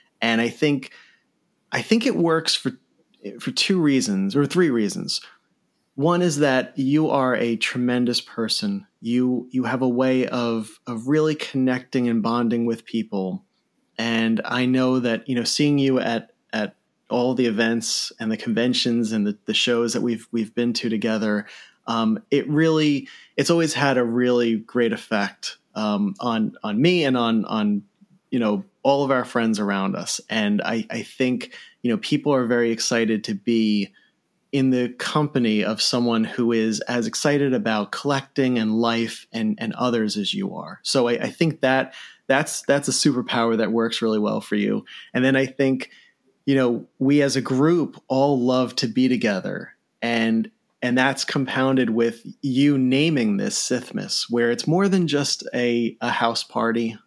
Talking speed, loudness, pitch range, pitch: 175 wpm, -22 LUFS, 115-140 Hz, 125 Hz